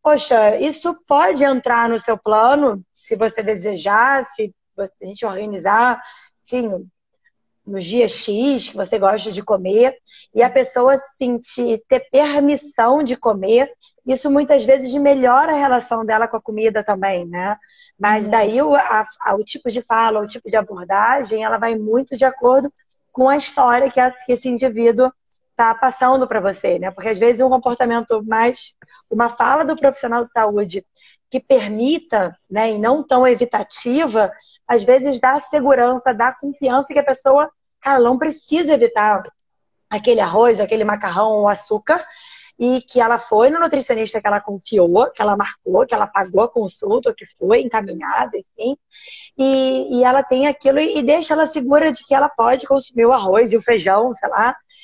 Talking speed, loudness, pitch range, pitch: 165 wpm, -16 LUFS, 220-275 Hz, 245 Hz